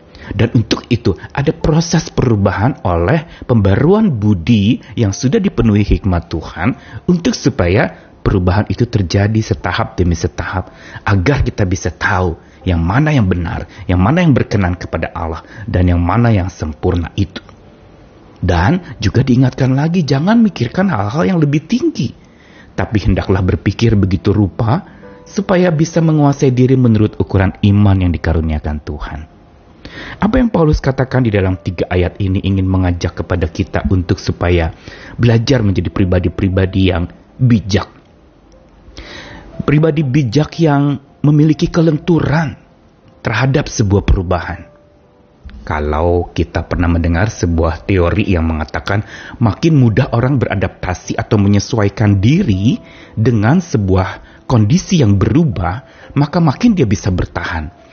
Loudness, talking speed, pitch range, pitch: -14 LUFS, 125 wpm, 90-130 Hz, 105 Hz